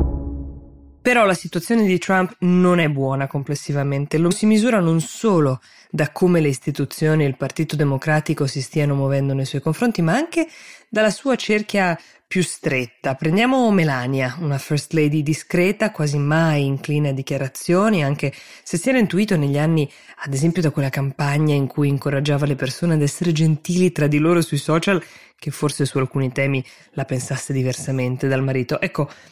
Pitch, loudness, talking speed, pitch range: 150 Hz, -20 LUFS, 170 wpm, 140-175 Hz